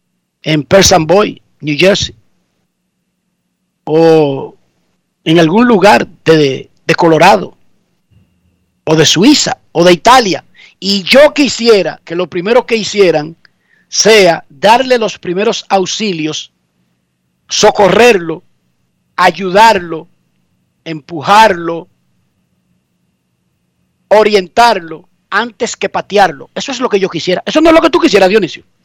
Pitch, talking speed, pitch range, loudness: 180 Hz, 110 wpm, 150-210 Hz, -9 LUFS